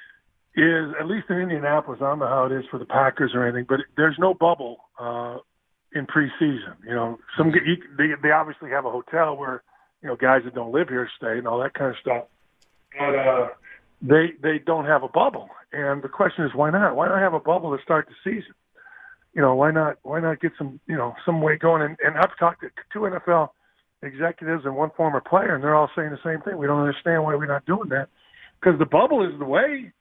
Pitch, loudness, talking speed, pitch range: 155 Hz, -22 LUFS, 235 wpm, 135-165 Hz